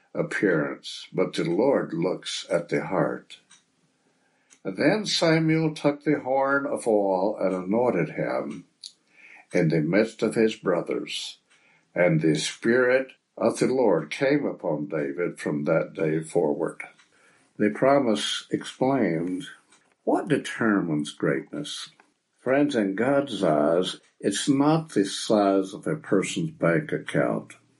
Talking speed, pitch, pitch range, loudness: 125 wpm, 115 Hz, 95-140 Hz, -25 LUFS